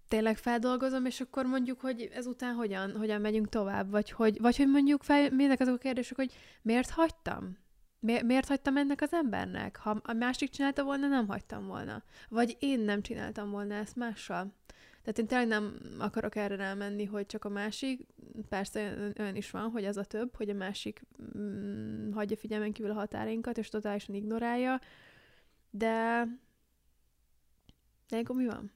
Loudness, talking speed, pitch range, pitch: -33 LUFS, 165 wpm, 210-255 Hz, 225 Hz